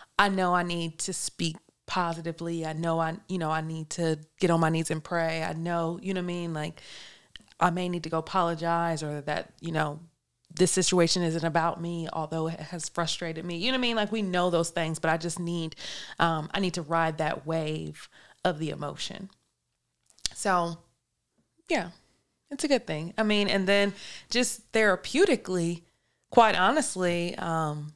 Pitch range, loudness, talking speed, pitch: 160-185 Hz, -28 LUFS, 190 wpm, 170 Hz